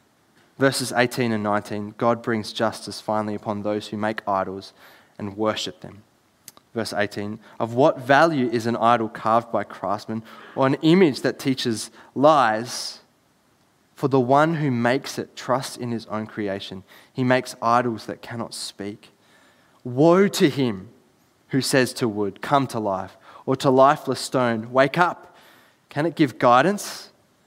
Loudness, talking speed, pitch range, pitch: -22 LUFS, 155 wpm, 105-135 Hz, 120 Hz